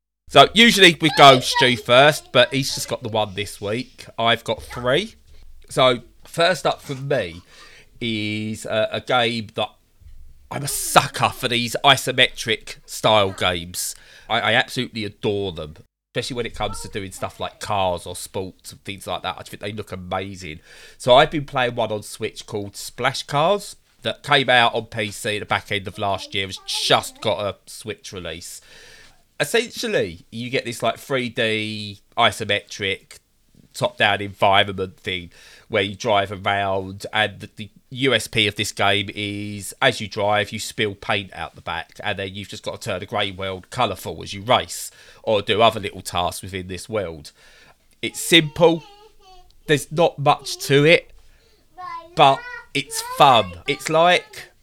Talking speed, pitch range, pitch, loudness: 170 wpm, 100-130 Hz, 110 Hz, -20 LUFS